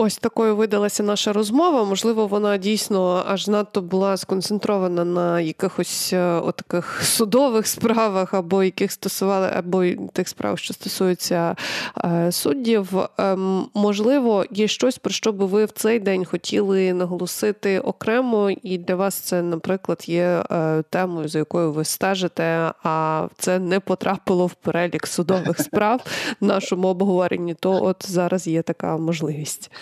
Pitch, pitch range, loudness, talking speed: 190 Hz, 175-210 Hz, -21 LUFS, 135 wpm